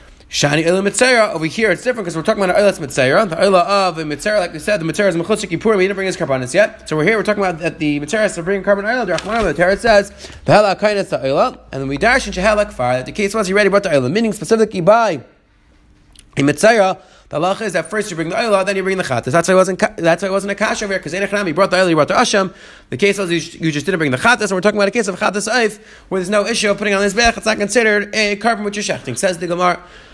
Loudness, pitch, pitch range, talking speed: -15 LUFS, 195 Hz, 170-210 Hz, 270 wpm